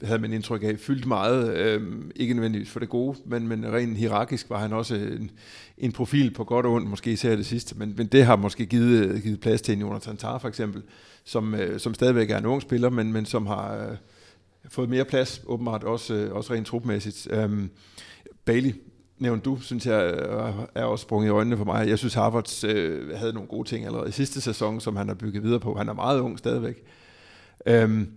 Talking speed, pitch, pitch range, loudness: 210 wpm, 115 Hz, 105-120 Hz, -26 LUFS